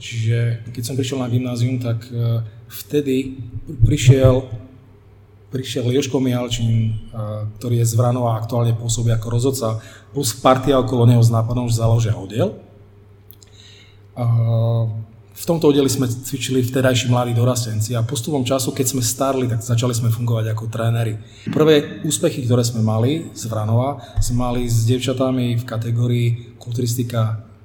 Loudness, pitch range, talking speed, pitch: -19 LUFS, 110-130 Hz, 145 wpm, 120 Hz